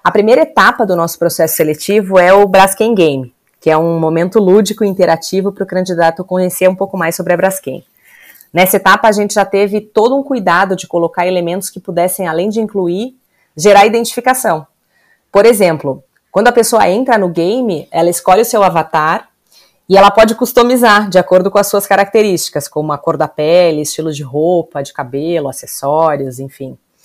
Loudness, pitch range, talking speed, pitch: -11 LUFS, 165-205 Hz, 180 wpm, 185 Hz